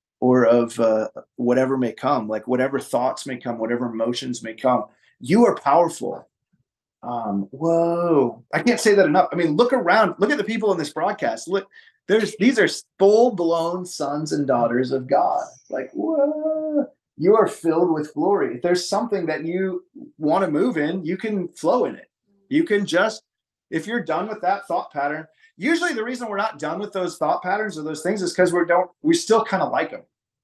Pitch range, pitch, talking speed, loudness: 140-220 Hz, 175 Hz, 195 wpm, -21 LUFS